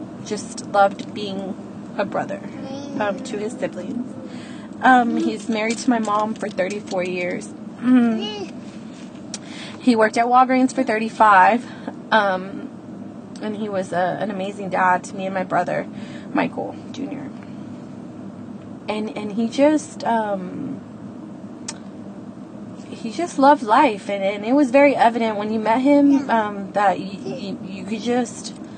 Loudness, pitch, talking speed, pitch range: -20 LUFS, 225 Hz, 140 wpm, 205-255 Hz